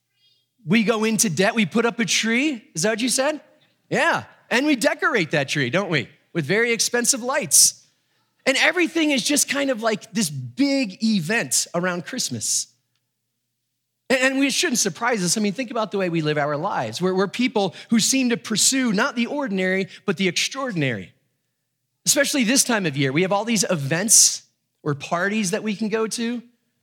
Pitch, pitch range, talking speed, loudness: 215 Hz, 170-245 Hz, 185 wpm, -20 LUFS